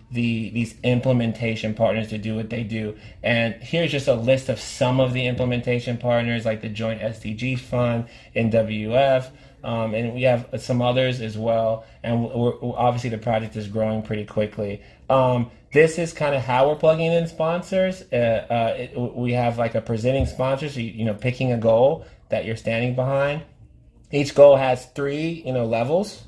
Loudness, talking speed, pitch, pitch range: -22 LUFS, 185 wpm, 120 Hz, 110-130 Hz